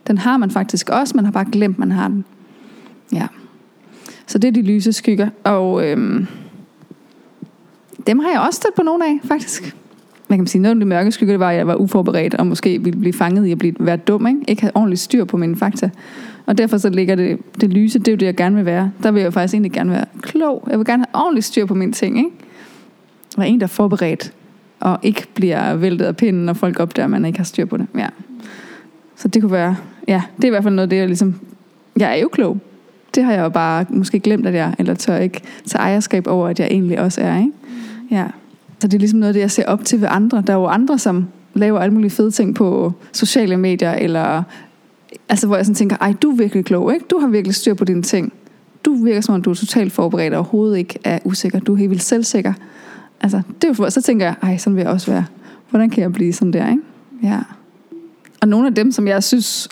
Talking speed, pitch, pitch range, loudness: 250 wpm, 210 Hz, 190-235 Hz, -16 LUFS